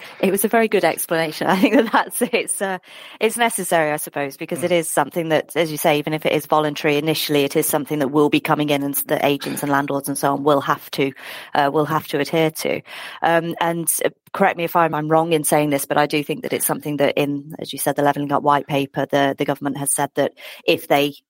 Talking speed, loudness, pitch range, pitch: 255 wpm, -19 LUFS, 145-165 Hz, 150 Hz